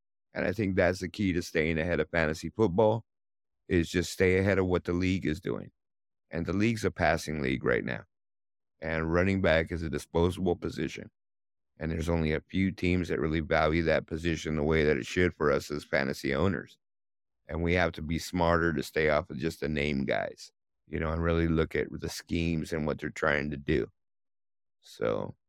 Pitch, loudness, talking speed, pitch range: 80 Hz, -29 LUFS, 205 wpm, 75-90 Hz